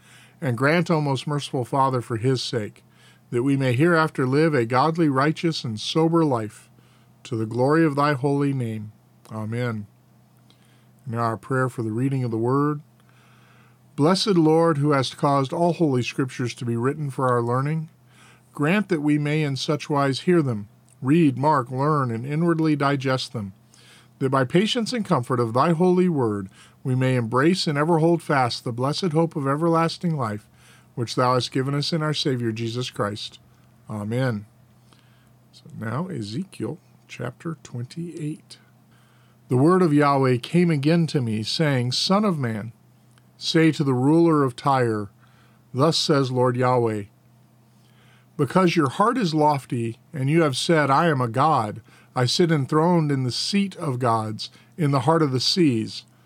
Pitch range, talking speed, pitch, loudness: 120-155 Hz, 165 wpm, 135 Hz, -22 LUFS